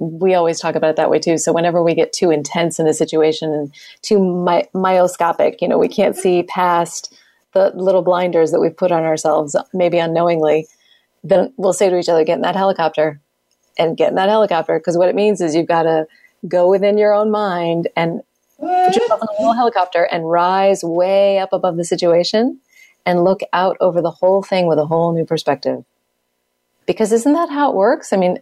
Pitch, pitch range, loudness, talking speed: 175 Hz, 165-195 Hz, -16 LUFS, 210 wpm